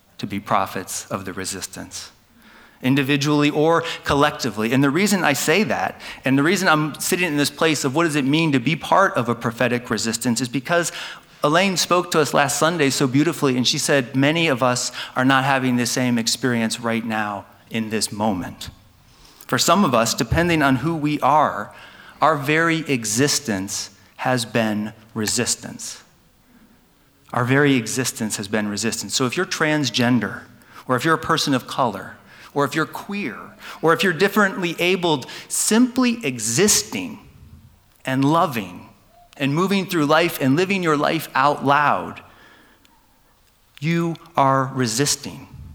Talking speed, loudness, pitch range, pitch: 155 wpm, -20 LUFS, 120-165 Hz, 140 Hz